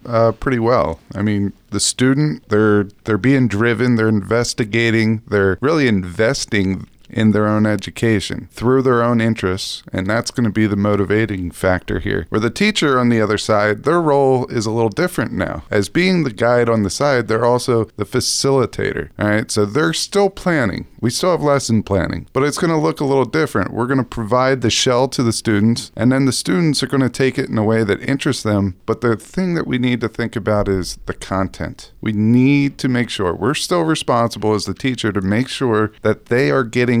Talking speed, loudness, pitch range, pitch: 210 wpm, -17 LUFS, 105-130 Hz, 115 Hz